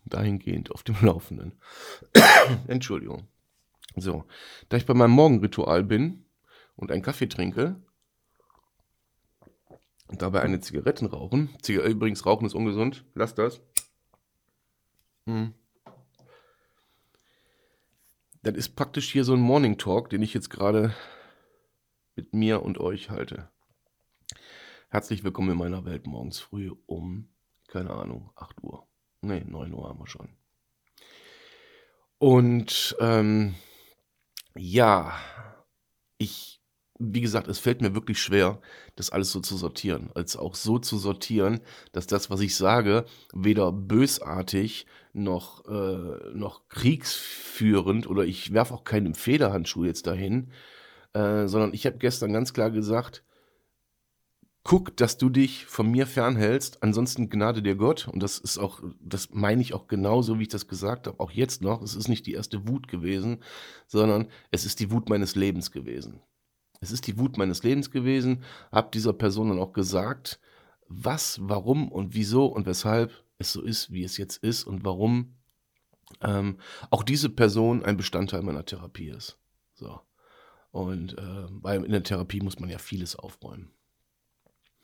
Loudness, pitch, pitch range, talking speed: -26 LUFS, 105 Hz, 95-120 Hz, 145 wpm